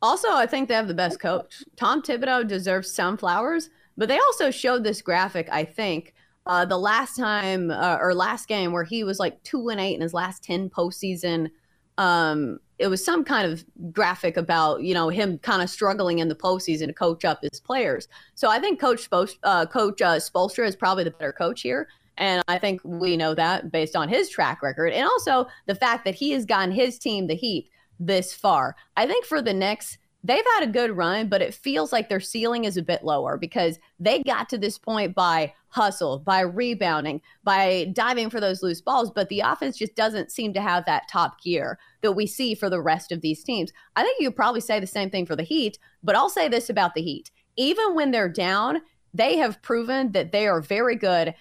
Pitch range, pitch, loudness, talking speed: 175-235 Hz, 195 Hz, -24 LUFS, 220 wpm